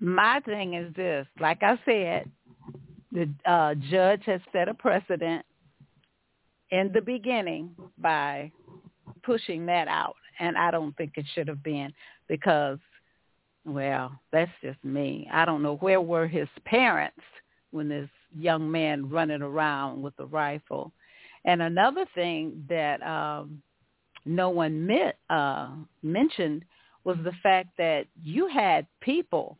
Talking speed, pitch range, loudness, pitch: 135 wpm, 150-185 Hz, -27 LUFS, 165 Hz